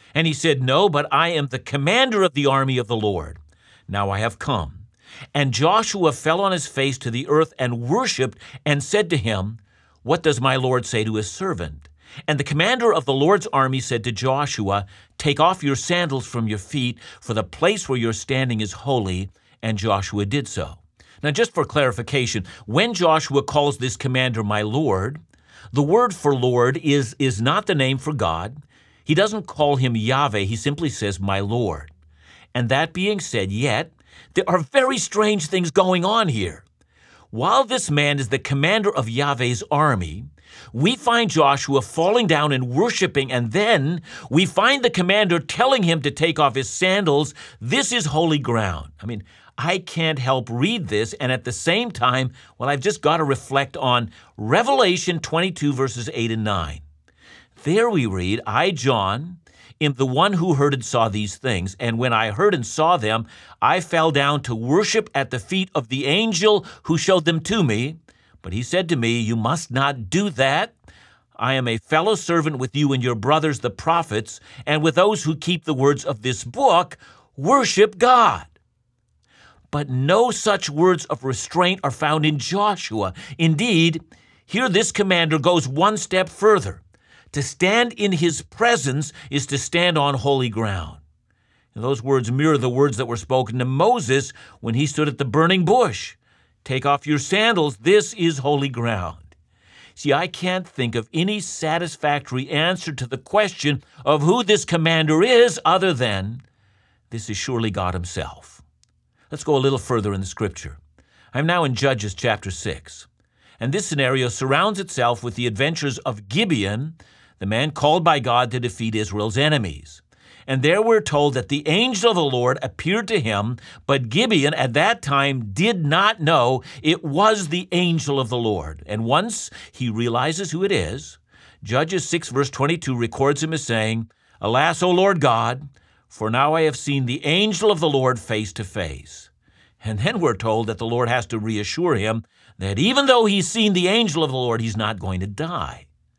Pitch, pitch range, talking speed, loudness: 135 Hz, 115-165 Hz, 180 wpm, -20 LUFS